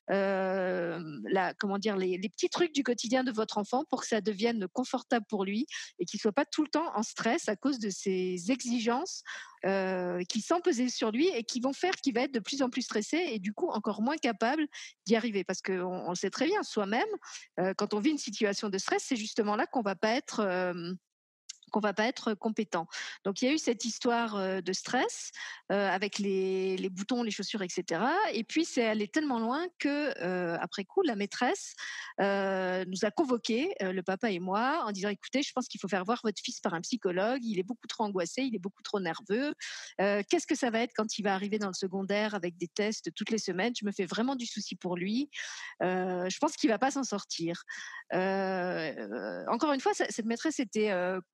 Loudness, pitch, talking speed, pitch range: -32 LUFS, 215 Hz, 225 wpm, 190-255 Hz